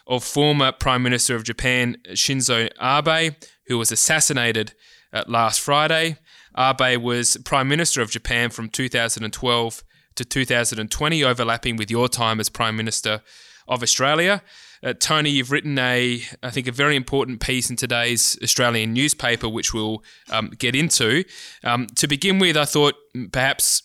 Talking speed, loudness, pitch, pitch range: 150 wpm, -20 LUFS, 125 Hz, 115-145 Hz